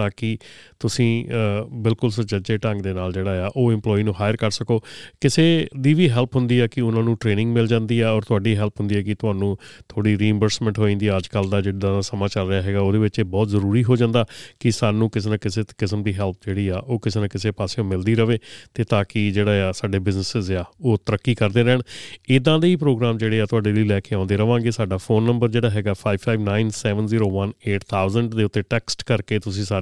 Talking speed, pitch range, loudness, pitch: 210 wpm, 100-115 Hz, -21 LUFS, 110 Hz